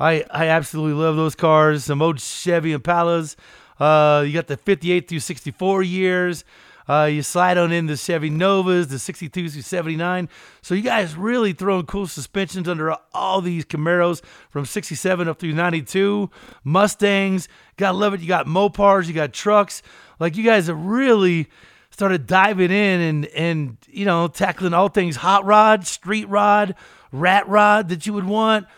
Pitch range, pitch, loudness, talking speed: 160-195 Hz, 180 Hz, -19 LUFS, 170 wpm